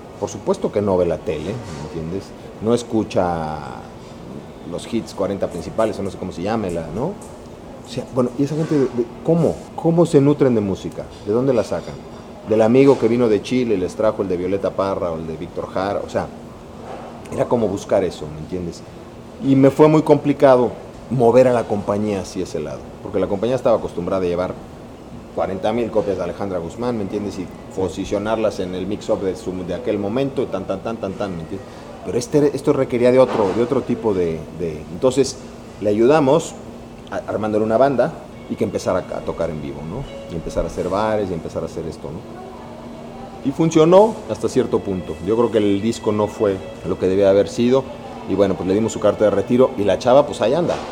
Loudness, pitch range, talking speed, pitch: -19 LUFS, 90-125 Hz, 210 wpm, 105 Hz